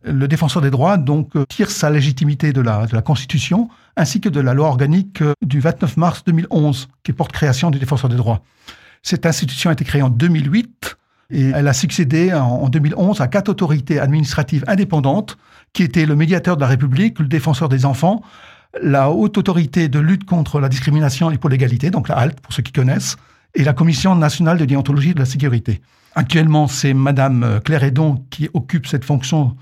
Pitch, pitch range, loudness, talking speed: 150 Hz, 135-170 Hz, -16 LUFS, 195 wpm